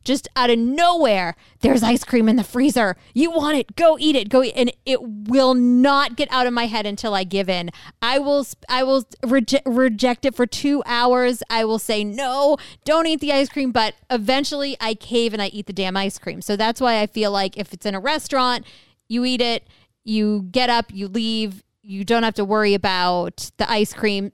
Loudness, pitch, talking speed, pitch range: -20 LUFS, 240 Hz, 220 wpm, 210-265 Hz